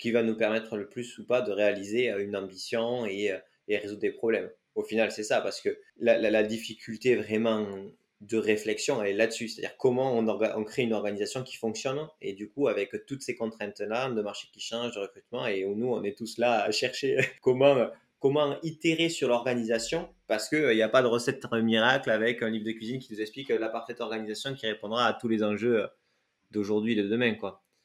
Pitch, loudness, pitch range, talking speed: 115 Hz, -29 LUFS, 105-125 Hz, 215 wpm